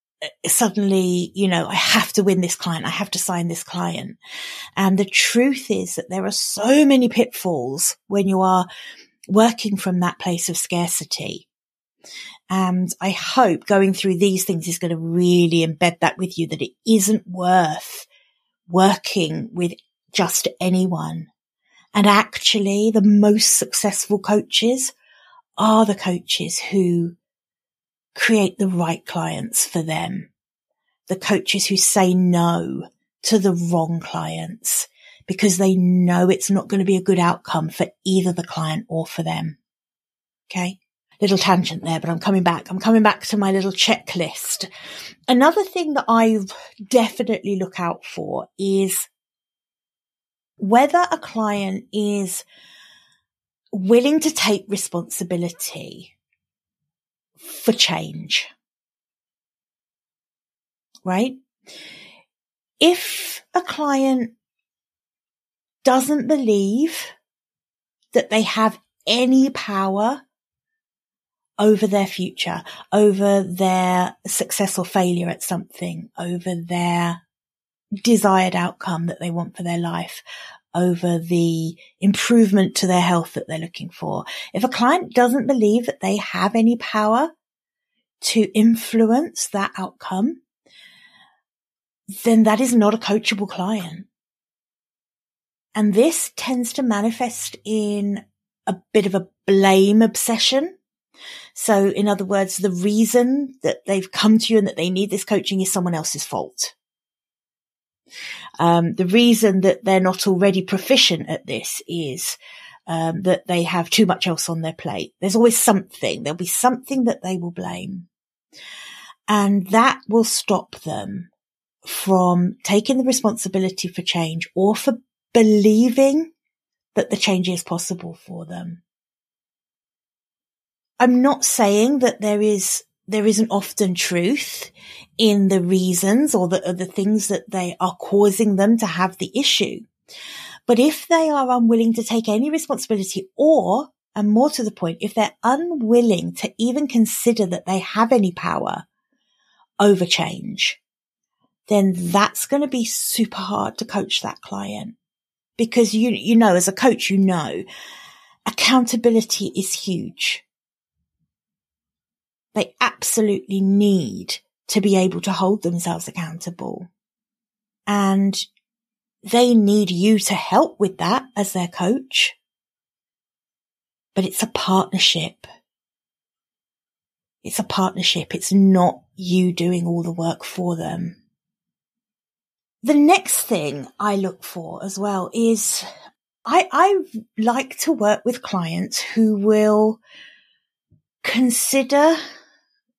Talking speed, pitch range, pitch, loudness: 130 wpm, 180-230 Hz, 200 Hz, -19 LUFS